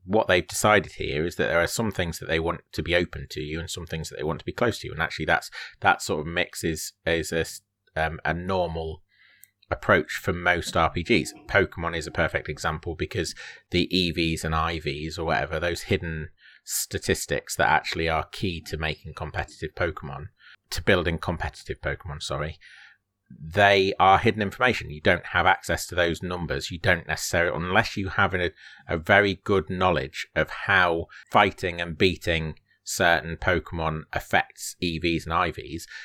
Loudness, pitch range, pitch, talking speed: -25 LUFS, 80-95 Hz, 85 Hz, 180 wpm